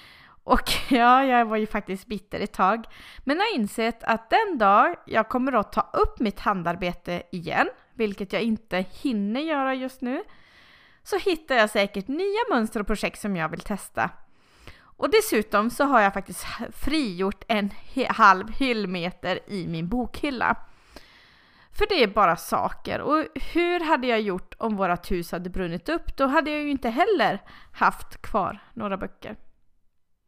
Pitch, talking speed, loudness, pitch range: 225 Hz, 165 wpm, -24 LUFS, 195-275 Hz